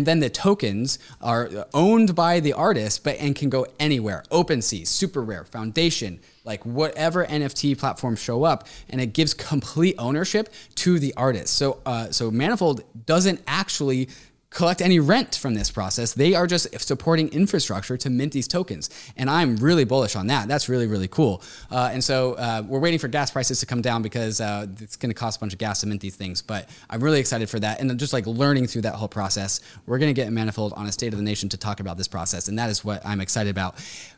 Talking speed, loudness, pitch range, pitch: 225 wpm, -23 LUFS, 110-150 Hz, 125 Hz